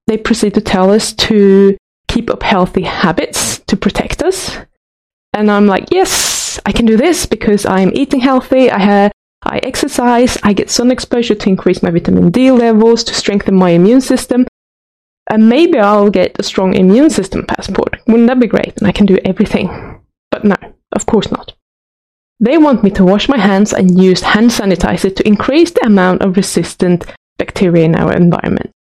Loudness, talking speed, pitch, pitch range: -11 LUFS, 180 wpm, 210 Hz, 190-245 Hz